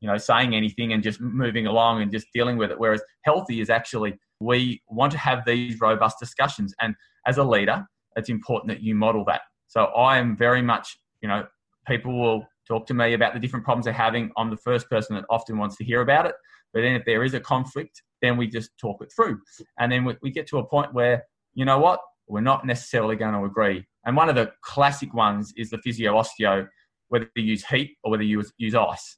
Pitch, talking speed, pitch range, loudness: 115 Hz, 230 wpm, 110-125 Hz, -23 LUFS